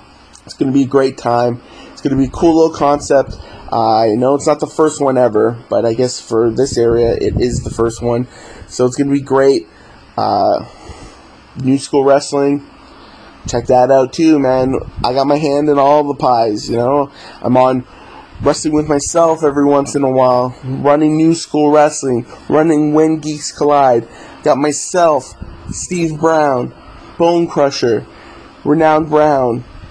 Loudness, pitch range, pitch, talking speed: -13 LUFS, 120-150 Hz, 140 Hz, 175 wpm